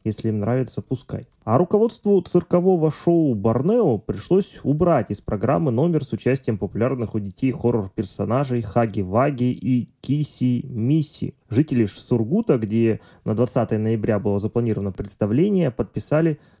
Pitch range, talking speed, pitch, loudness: 110-150 Hz, 125 wpm, 125 Hz, -22 LUFS